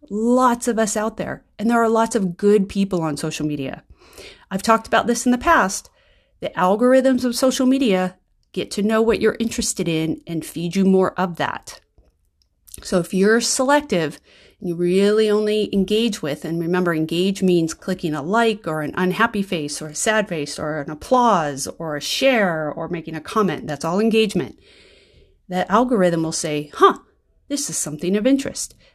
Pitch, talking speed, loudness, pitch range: 190 Hz, 180 wpm, -20 LUFS, 160-225 Hz